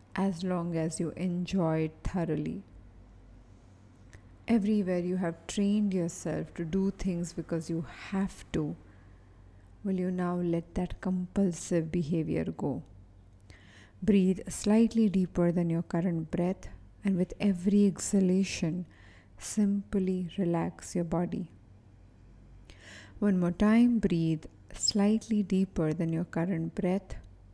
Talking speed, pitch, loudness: 115 wpm, 175 Hz, -30 LUFS